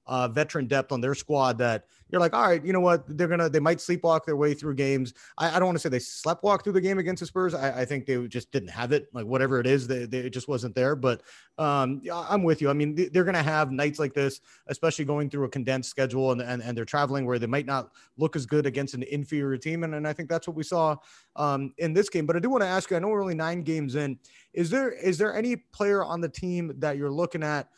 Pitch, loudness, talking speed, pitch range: 150 Hz, -27 LUFS, 280 wpm, 135-170 Hz